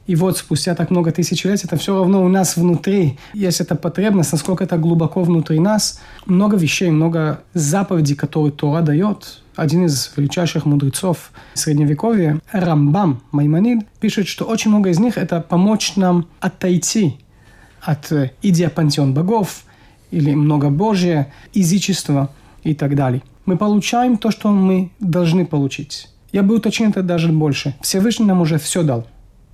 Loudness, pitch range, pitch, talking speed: -17 LUFS, 150-190 Hz, 170 Hz, 150 wpm